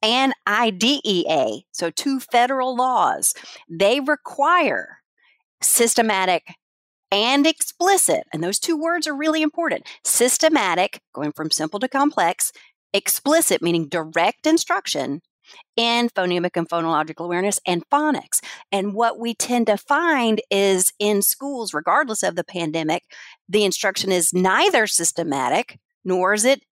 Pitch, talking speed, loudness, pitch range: 220 Hz, 125 wpm, -20 LUFS, 180-285 Hz